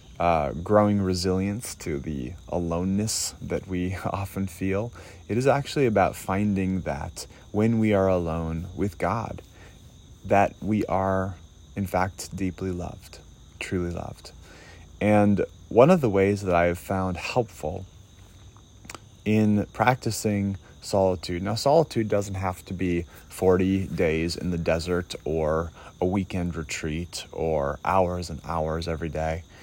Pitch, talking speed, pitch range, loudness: 95 Hz, 130 wpm, 85-100 Hz, -26 LUFS